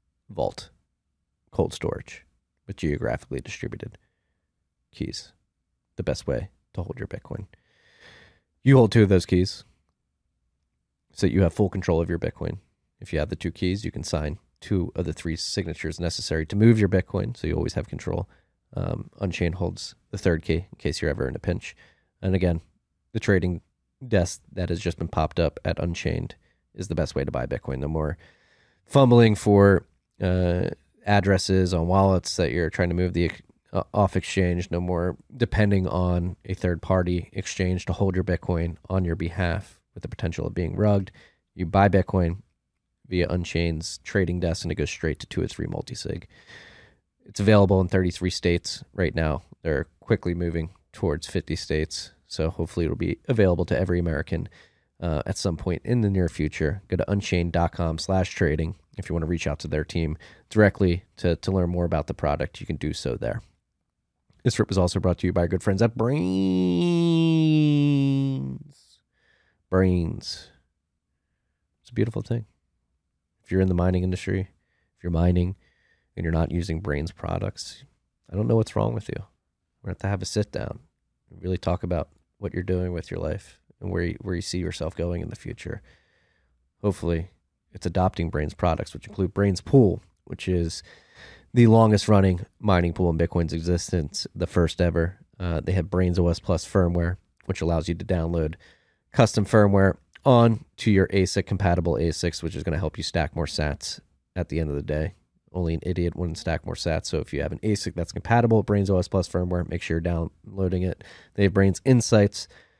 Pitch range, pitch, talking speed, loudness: 80-100 Hz, 90 Hz, 185 wpm, -25 LUFS